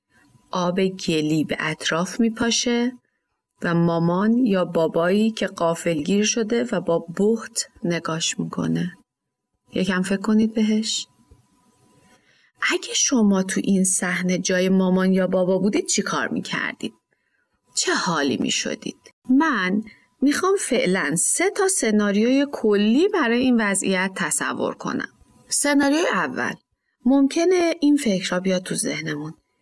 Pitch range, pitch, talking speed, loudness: 180-245 Hz, 200 Hz, 125 wpm, -21 LUFS